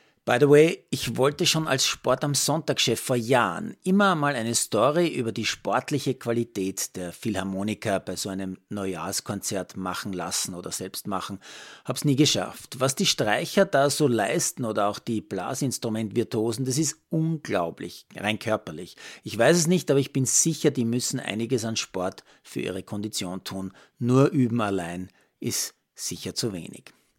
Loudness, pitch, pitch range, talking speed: -25 LUFS, 120 Hz, 100-140 Hz, 160 wpm